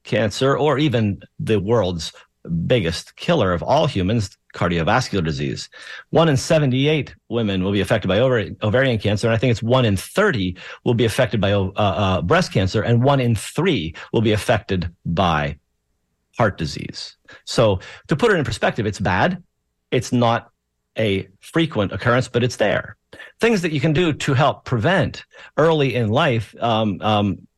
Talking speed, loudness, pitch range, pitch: 165 wpm, -20 LUFS, 95-130 Hz, 110 Hz